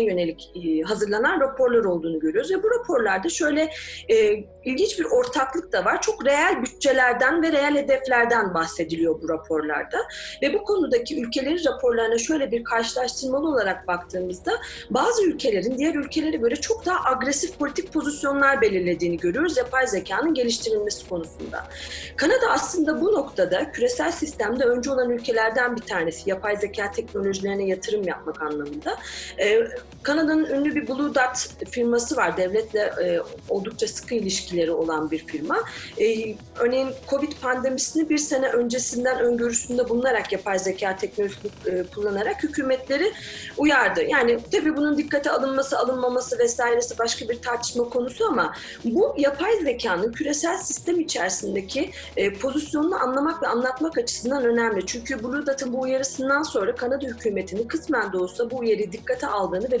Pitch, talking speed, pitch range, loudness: 260 Hz, 140 wpm, 225-315 Hz, -23 LUFS